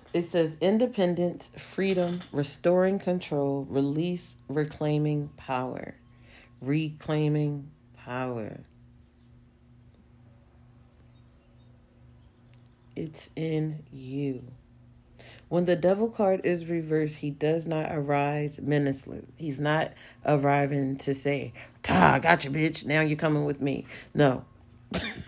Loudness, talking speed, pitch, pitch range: -28 LUFS, 95 wpm, 145 Hz, 125-160 Hz